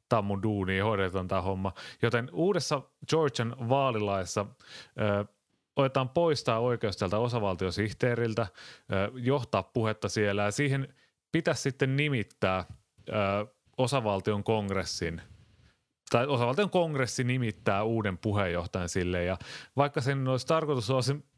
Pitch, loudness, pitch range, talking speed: 115 Hz, -30 LUFS, 100-135 Hz, 115 wpm